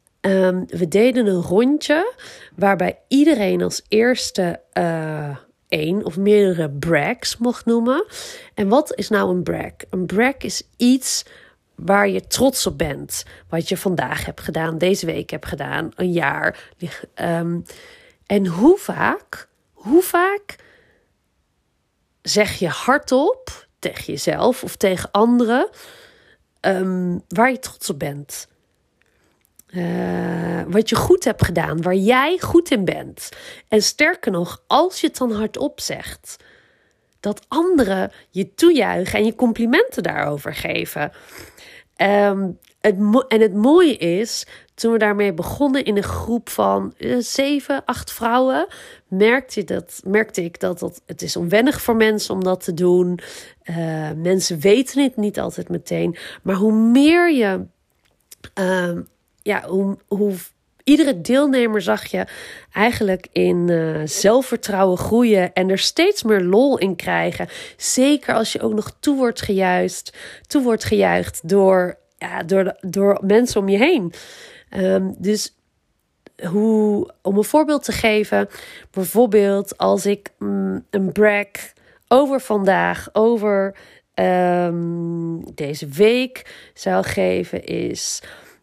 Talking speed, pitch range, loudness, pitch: 135 wpm, 180-255 Hz, -19 LUFS, 205 Hz